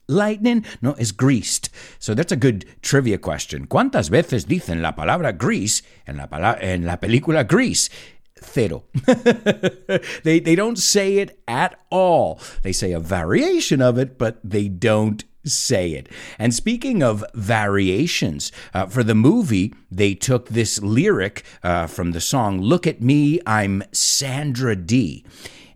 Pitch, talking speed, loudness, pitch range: 120 Hz, 145 wpm, -19 LUFS, 100-165 Hz